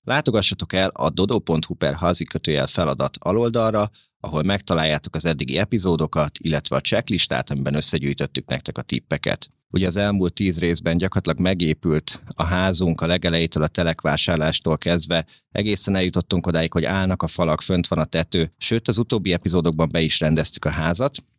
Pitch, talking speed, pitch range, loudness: 85 Hz, 155 wpm, 80-95 Hz, -21 LUFS